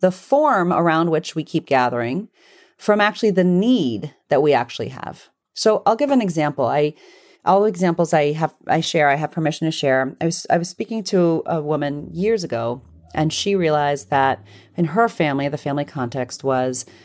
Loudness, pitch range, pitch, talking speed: -20 LUFS, 140-195 Hz, 160 Hz, 190 wpm